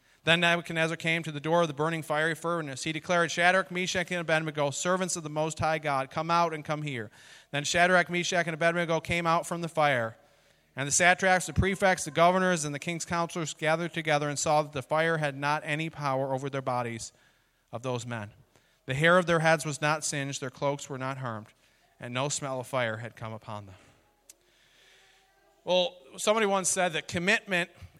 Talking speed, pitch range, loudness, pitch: 200 wpm, 140-170 Hz, -28 LUFS, 155 Hz